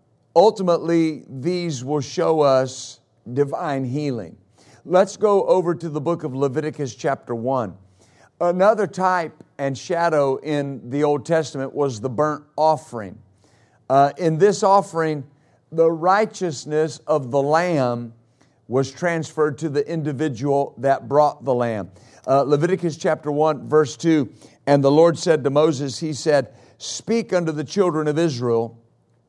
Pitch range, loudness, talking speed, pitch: 130-165 Hz, -20 LUFS, 135 wpm, 145 Hz